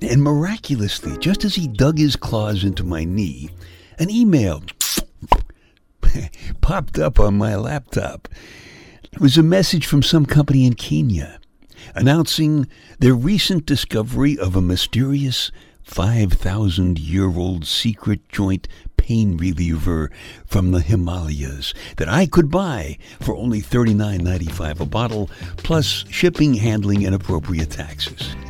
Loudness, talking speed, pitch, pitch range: -19 LUFS, 120 wpm, 105 Hz, 90-140 Hz